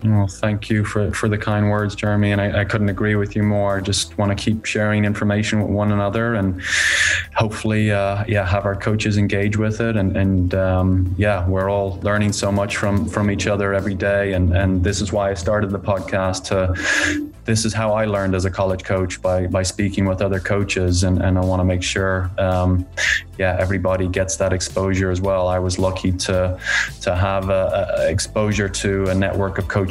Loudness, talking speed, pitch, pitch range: -19 LUFS, 215 wpm, 100 Hz, 95-105 Hz